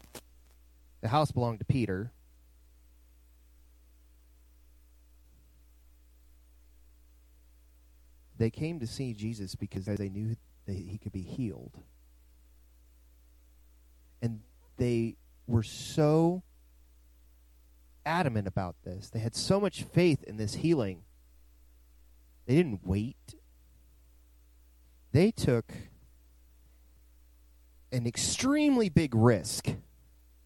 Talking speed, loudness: 85 wpm, -31 LUFS